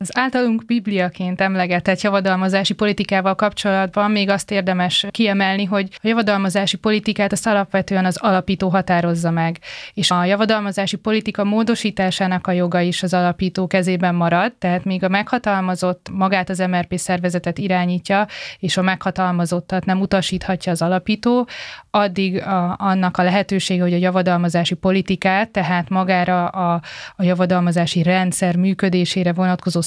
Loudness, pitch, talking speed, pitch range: -18 LUFS, 190 Hz, 135 wpm, 180-200 Hz